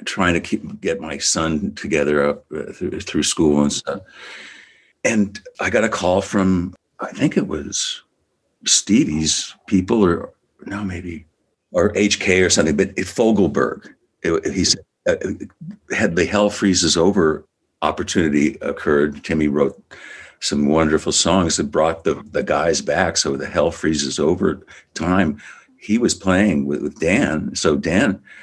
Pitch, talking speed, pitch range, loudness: 80 Hz, 150 wpm, 75-95 Hz, -19 LUFS